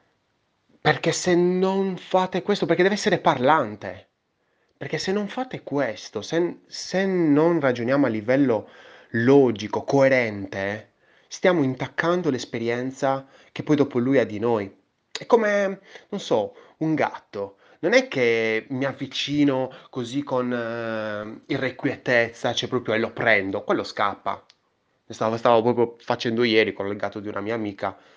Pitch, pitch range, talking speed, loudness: 135 Hz, 115-175 Hz, 140 wpm, -23 LUFS